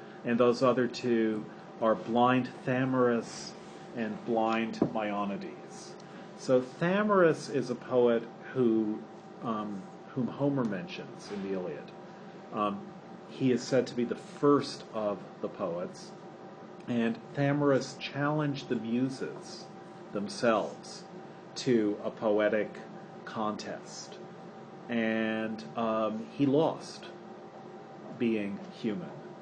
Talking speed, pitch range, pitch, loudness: 100 wpm, 110-145 Hz, 125 Hz, -31 LUFS